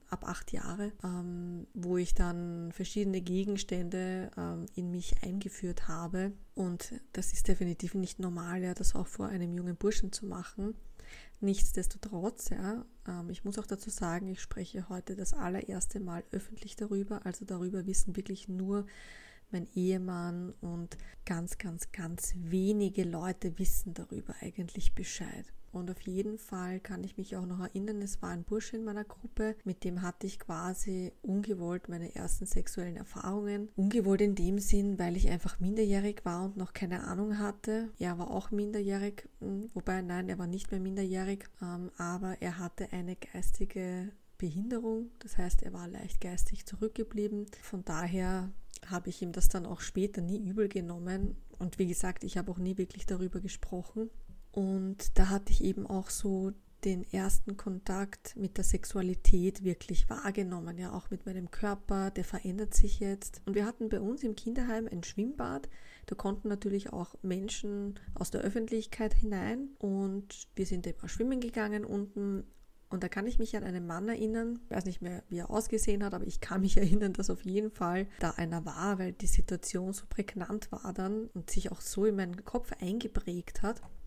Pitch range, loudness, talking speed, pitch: 180-205 Hz, -36 LUFS, 170 wpm, 195 Hz